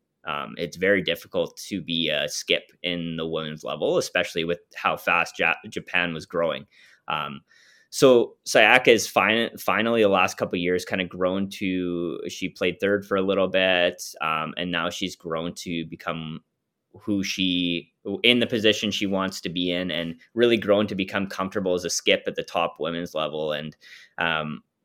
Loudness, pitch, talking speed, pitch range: -24 LUFS, 90 Hz, 180 wpm, 85-100 Hz